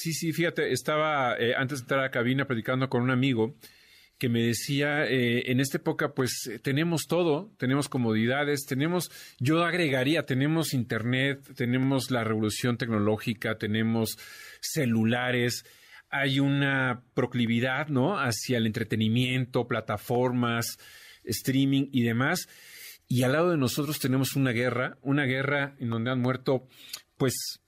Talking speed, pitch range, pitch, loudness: 140 wpm, 120-140 Hz, 130 Hz, -27 LUFS